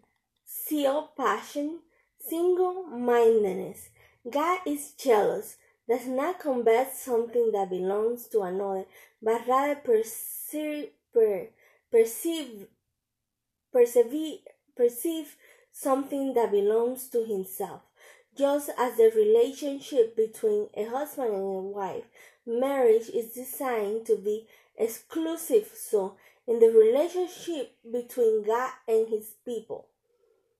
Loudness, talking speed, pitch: -27 LUFS, 100 wpm, 290 Hz